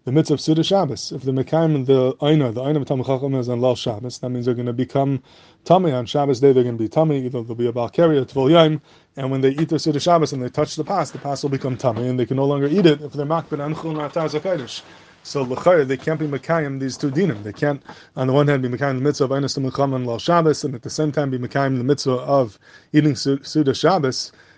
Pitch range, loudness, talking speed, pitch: 130-155 Hz, -20 LUFS, 255 wpm, 140 Hz